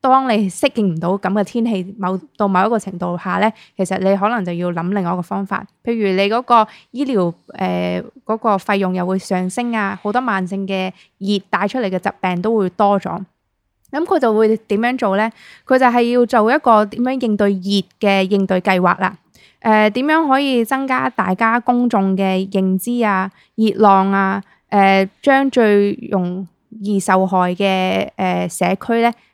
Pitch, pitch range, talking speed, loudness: 200 Hz, 190-230 Hz, 260 characters per minute, -17 LUFS